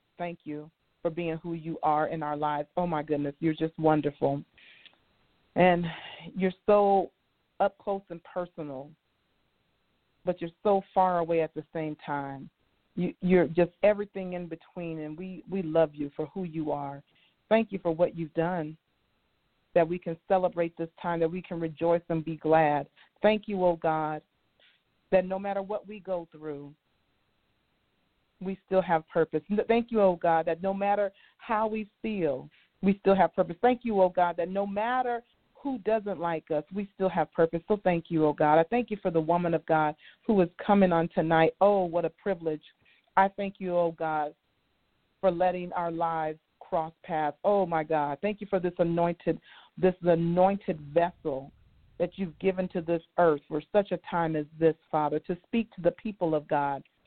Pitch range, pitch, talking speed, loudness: 160-190 Hz, 170 Hz, 185 wpm, -28 LUFS